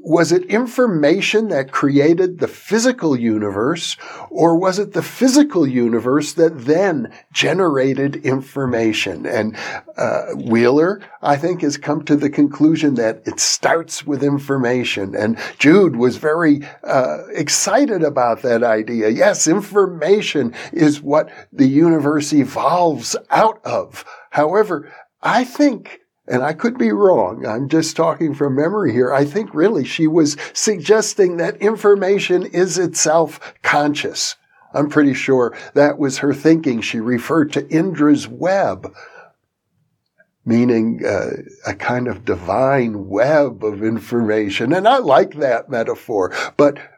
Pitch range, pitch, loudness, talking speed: 135-180 Hz, 150 Hz, -16 LUFS, 130 wpm